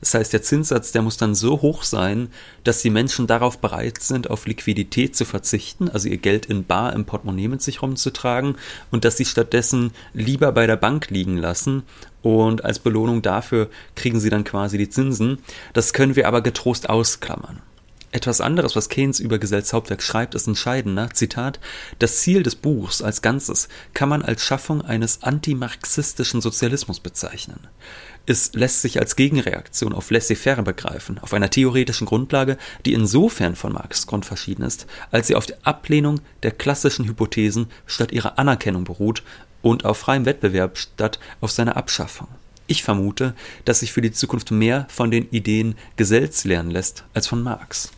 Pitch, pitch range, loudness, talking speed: 115 Hz, 110-130 Hz, -20 LUFS, 170 wpm